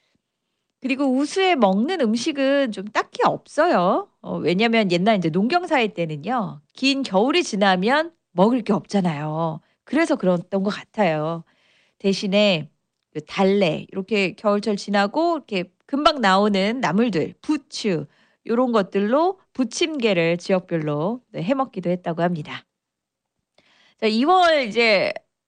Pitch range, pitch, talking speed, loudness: 190-270 Hz, 210 Hz, 255 characters per minute, -21 LUFS